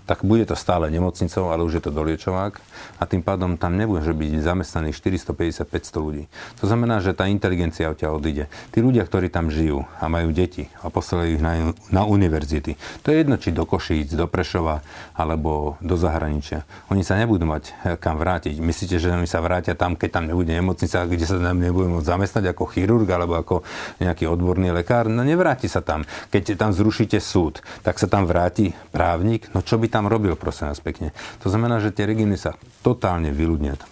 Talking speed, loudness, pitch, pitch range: 195 wpm, -22 LUFS, 90 Hz, 80-100 Hz